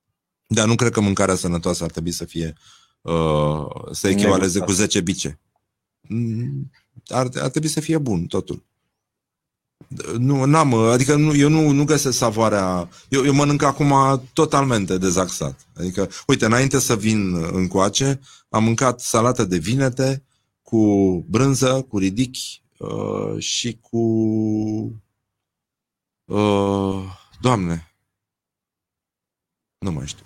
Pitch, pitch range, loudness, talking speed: 110 Hz, 95-130 Hz, -20 LUFS, 125 wpm